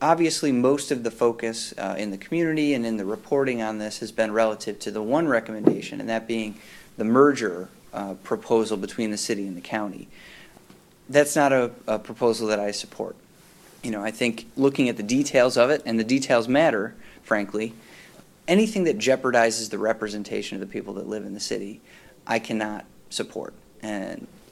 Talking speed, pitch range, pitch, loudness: 185 wpm, 110-135 Hz, 115 Hz, -24 LUFS